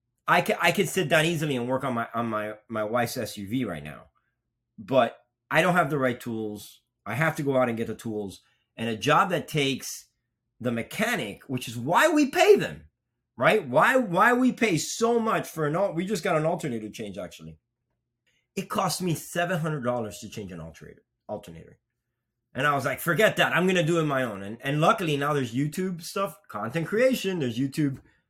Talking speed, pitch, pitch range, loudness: 210 wpm, 130 Hz, 115-170 Hz, -25 LUFS